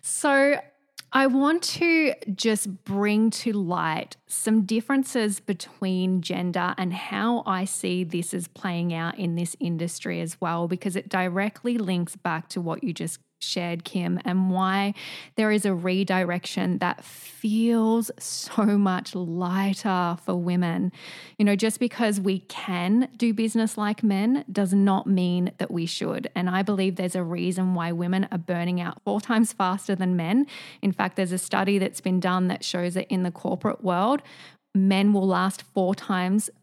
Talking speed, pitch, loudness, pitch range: 165 wpm, 190 Hz, -25 LUFS, 180-220 Hz